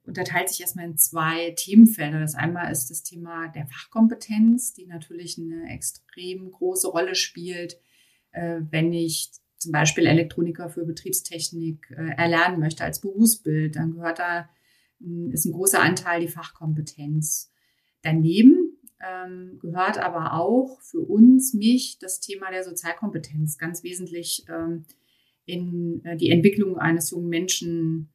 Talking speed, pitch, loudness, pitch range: 125 wpm, 170 Hz, -22 LUFS, 160-185 Hz